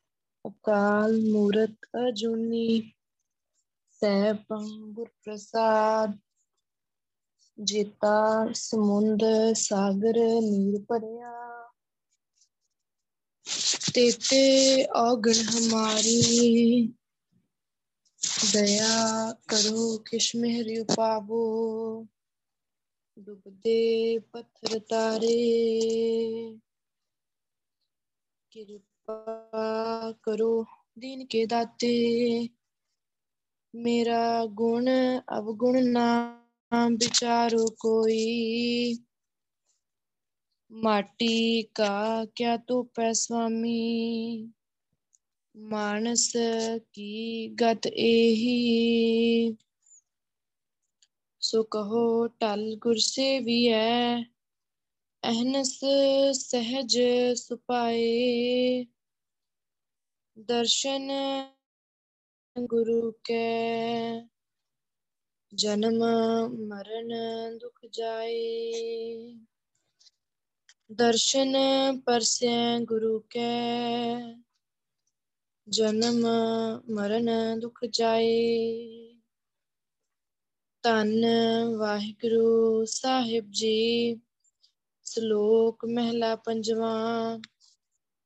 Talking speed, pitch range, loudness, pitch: 50 wpm, 225-235 Hz, -26 LUFS, 230 Hz